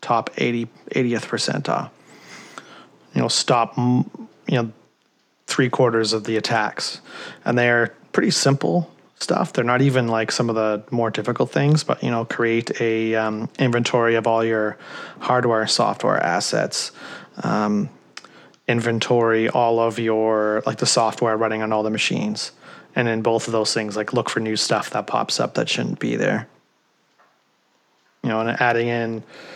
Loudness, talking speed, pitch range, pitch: -21 LUFS, 160 wpm, 110-125 Hz, 115 Hz